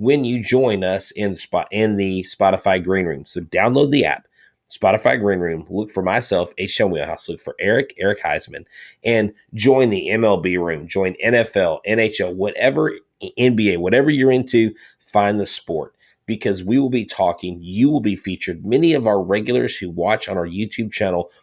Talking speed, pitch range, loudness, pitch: 175 wpm, 95-115 Hz, -19 LUFS, 105 Hz